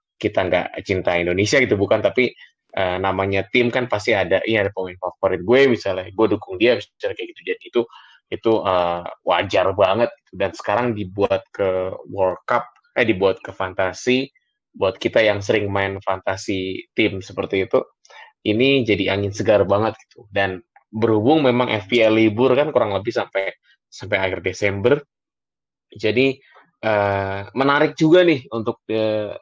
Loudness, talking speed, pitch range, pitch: -20 LUFS, 150 wpm, 95-130 Hz, 110 Hz